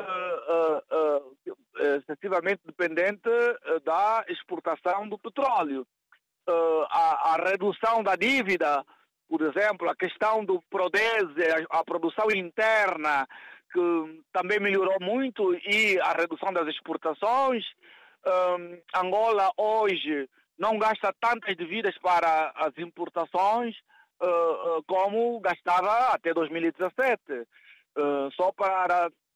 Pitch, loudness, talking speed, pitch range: 185 Hz, -26 LUFS, 110 wpm, 165-220 Hz